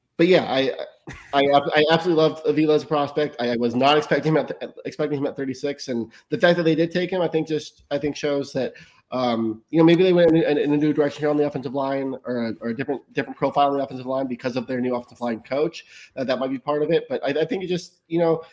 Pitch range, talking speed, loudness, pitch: 130-155 Hz, 280 wpm, -22 LUFS, 145 Hz